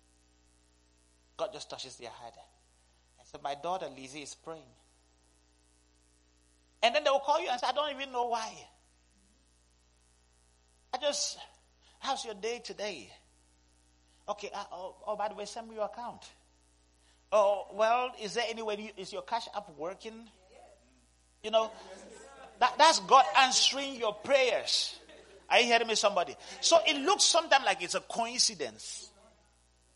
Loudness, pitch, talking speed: -29 LUFS, 160 Hz, 150 wpm